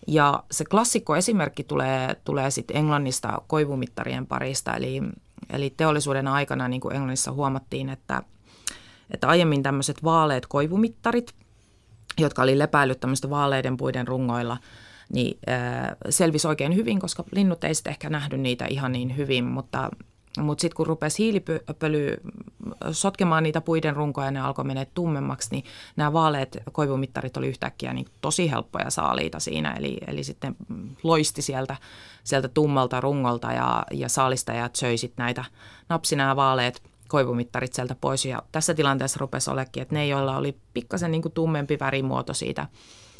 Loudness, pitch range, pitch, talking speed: -25 LUFS, 125-155 Hz, 135 Hz, 140 wpm